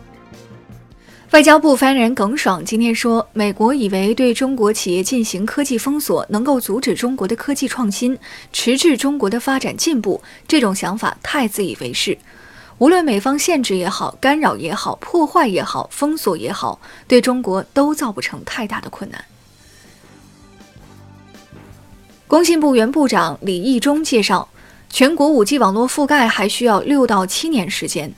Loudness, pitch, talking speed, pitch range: -16 LUFS, 245 Hz, 245 characters per minute, 205-285 Hz